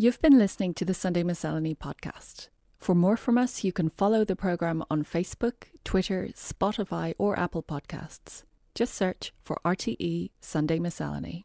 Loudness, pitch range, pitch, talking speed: -28 LUFS, 165-205 Hz, 180 Hz, 155 wpm